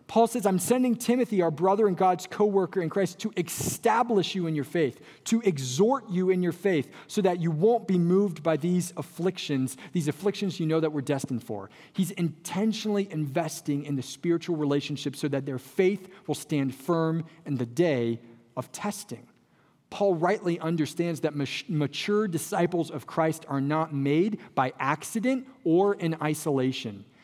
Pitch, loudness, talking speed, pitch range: 170 Hz, -27 LUFS, 170 wpm, 145-195 Hz